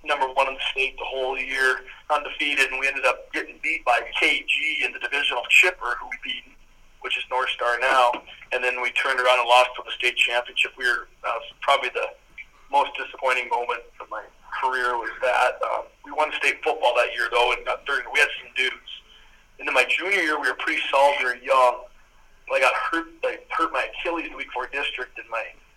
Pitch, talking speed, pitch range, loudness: 130 Hz, 215 wpm, 125-155 Hz, -22 LUFS